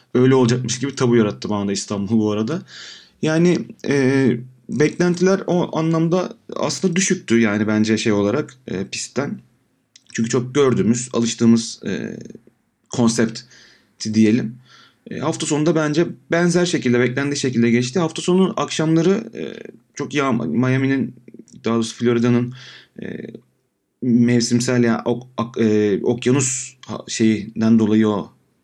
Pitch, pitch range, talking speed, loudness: 125 Hz, 115-155 Hz, 120 wpm, -19 LUFS